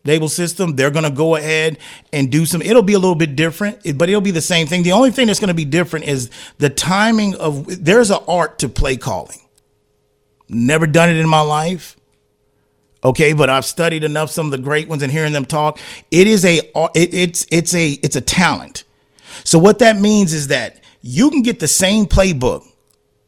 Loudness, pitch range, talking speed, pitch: -15 LUFS, 145-180 Hz, 210 wpm, 160 Hz